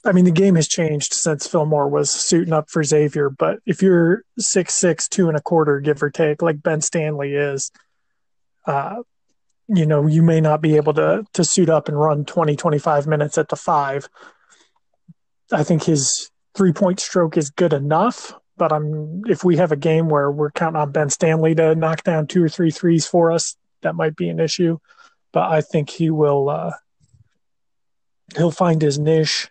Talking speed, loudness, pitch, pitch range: 195 wpm, -18 LUFS, 160 Hz, 150-175 Hz